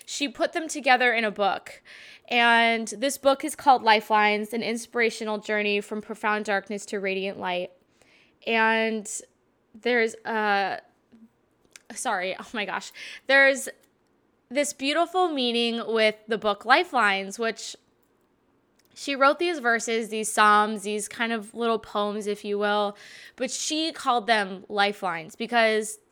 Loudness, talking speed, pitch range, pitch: -24 LUFS, 135 wpm, 210-245 Hz, 225 Hz